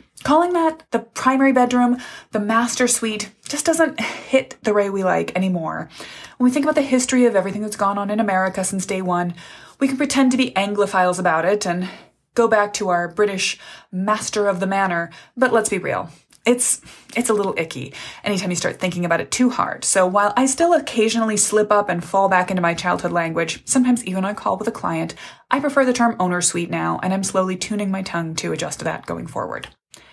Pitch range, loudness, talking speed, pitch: 185-250 Hz, -19 LUFS, 215 wpm, 205 Hz